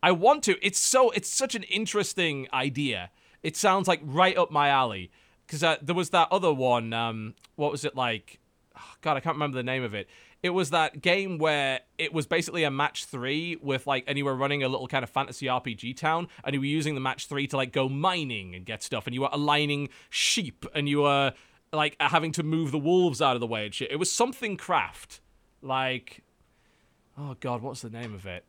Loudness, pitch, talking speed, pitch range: -27 LUFS, 145 Hz, 230 wpm, 130-165 Hz